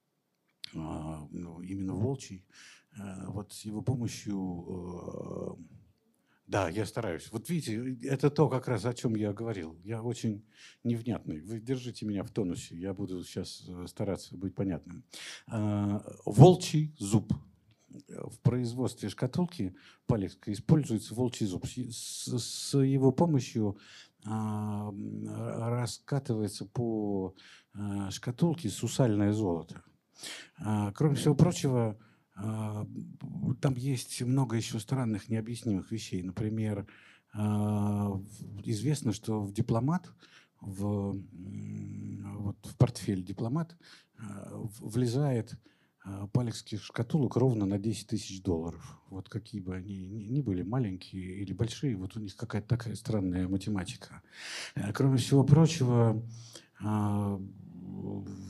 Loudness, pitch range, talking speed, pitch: -32 LUFS, 100-125 Hz, 100 wpm, 110 Hz